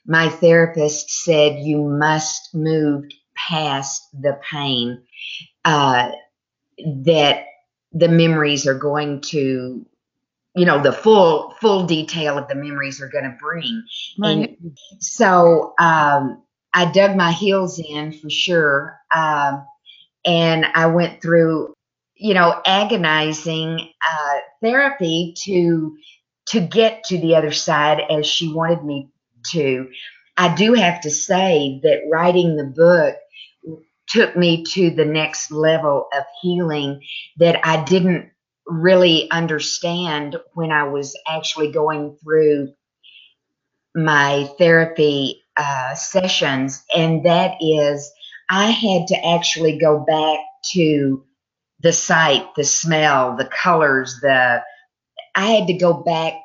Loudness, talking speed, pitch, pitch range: -17 LUFS, 120 wpm, 160 Hz, 145-175 Hz